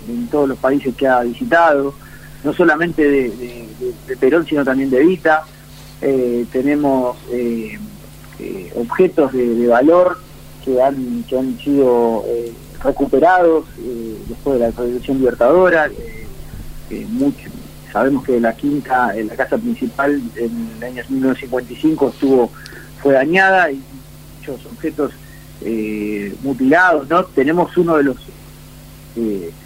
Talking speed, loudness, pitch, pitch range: 135 wpm, -16 LUFS, 135 Hz, 120-155 Hz